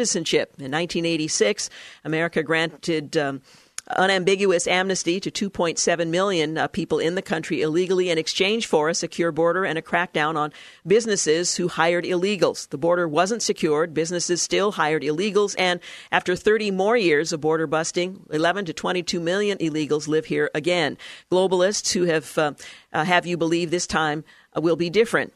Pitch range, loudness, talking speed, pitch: 160-185 Hz, -22 LUFS, 160 wpm, 170 Hz